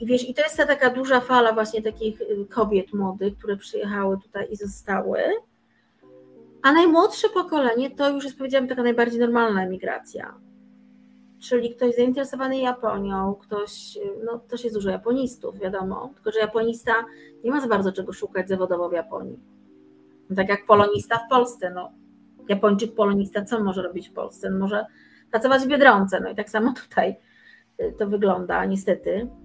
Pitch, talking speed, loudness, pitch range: 220 Hz, 160 wpm, -23 LUFS, 200-250 Hz